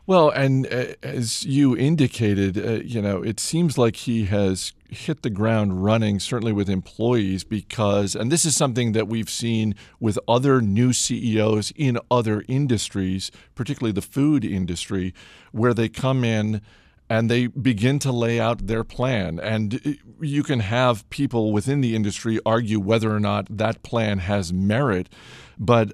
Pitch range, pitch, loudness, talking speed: 105-125 Hz, 115 Hz, -22 LUFS, 160 wpm